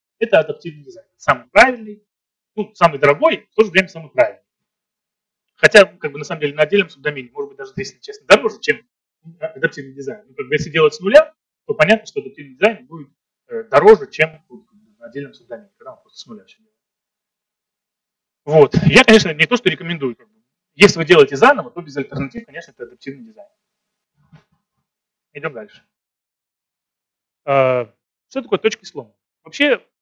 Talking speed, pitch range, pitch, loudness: 160 wpm, 160-215 Hz, 210 Hz, -14 LUFS